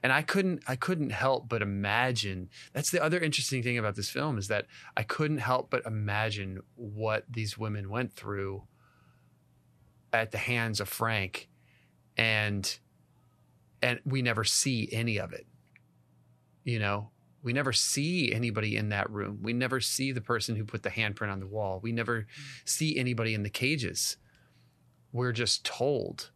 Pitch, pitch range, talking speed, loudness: 115 Hz, 105-130 Hz, 165 wpm, -31 LUFS